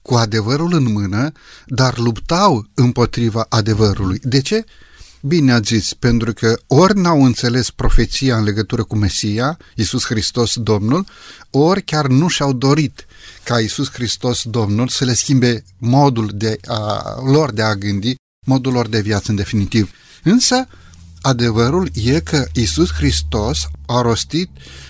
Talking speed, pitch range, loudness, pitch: 145 wpm, 110-135 Hz, -16 LUFS, 120 Hz